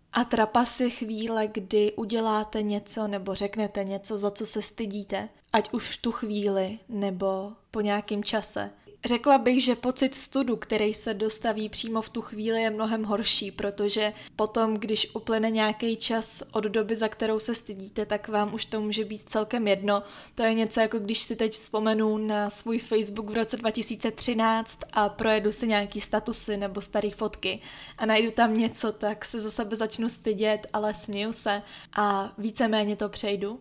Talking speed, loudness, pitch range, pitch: 170 wpm, -28 LUFS, 210-225 Hz, 220 Hz